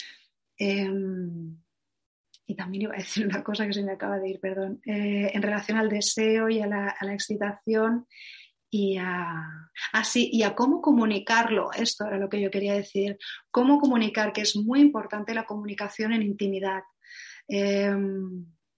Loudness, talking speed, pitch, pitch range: -26 LUFS, 165 wpm, 205 Hz, 195-220 Hz